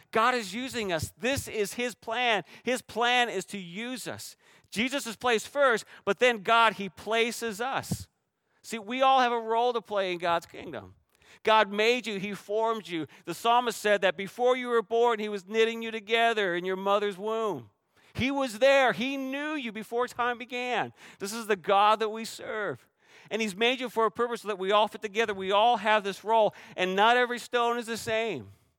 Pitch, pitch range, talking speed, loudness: 225 Hz, 205-240 Hz, 205 wpm, -27 LUFS